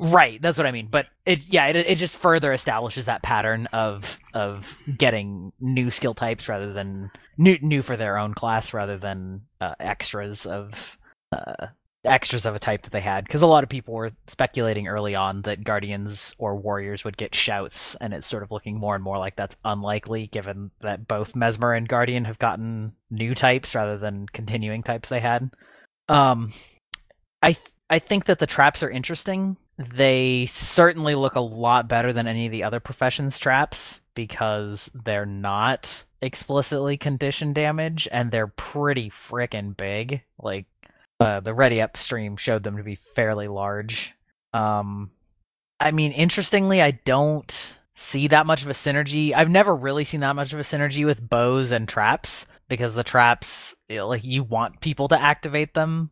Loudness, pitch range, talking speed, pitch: -23 LUFS, 105-140 Hz, 175 wpm, 120 Hz